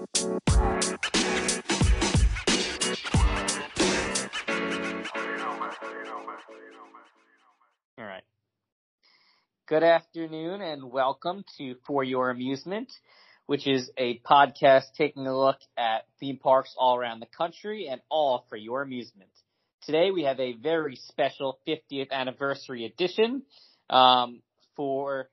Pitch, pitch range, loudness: 135 Hz, 125-155 Hz, -27 LUFS